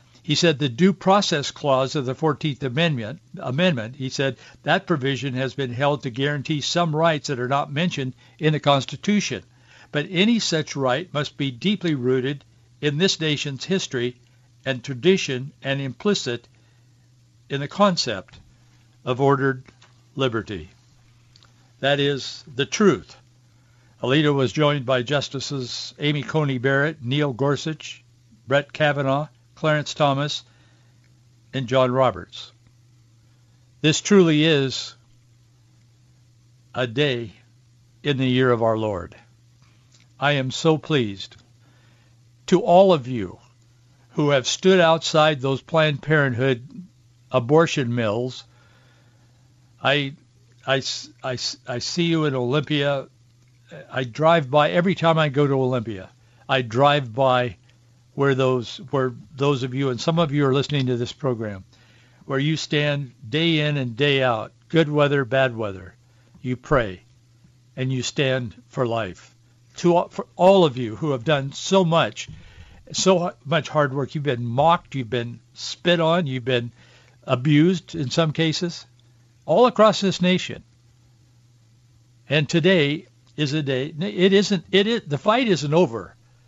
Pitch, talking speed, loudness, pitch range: 130 Hz, 135 wpm, -22 LUFS, 120-150 Hz